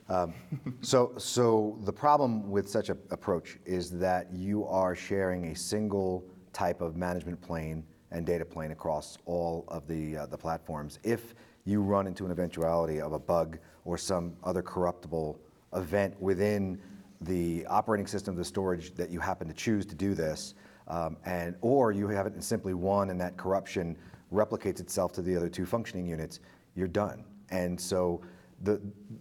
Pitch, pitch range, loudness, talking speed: 90 Hz, 85-100 Hz, -32 LUFS, 175 wpm